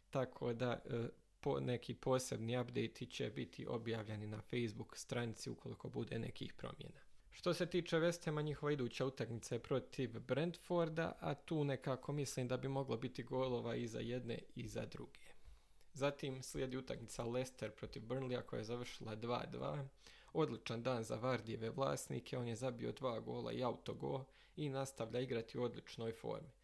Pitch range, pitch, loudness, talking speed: 115-140 Hz, 125 Hz, -44 LUFS, 160 wpm